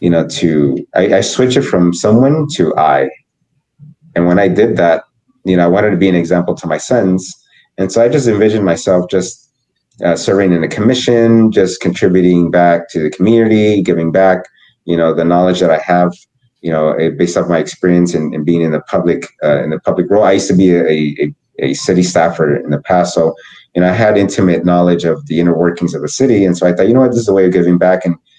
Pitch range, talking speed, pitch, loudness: 85-110 Hz, 235 wpm, 90 Hz, -12 LUFS